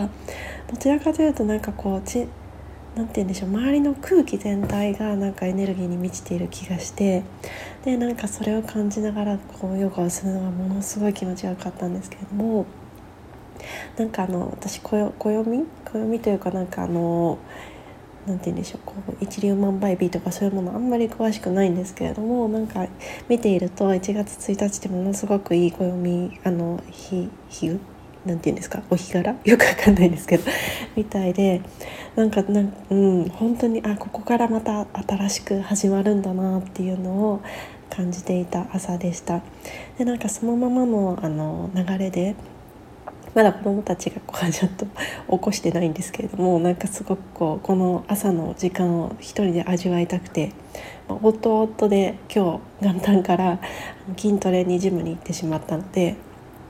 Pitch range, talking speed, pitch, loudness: 180-215 Hz, 350 characters per minute, 195 Hz, -23 LUFS